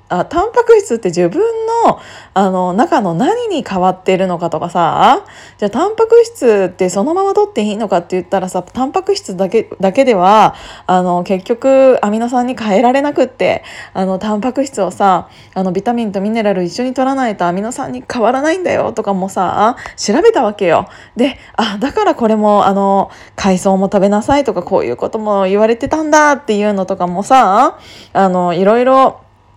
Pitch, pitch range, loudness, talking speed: 215 Hz, 190-270 Hz, -13 LUFS, 370 characters per minute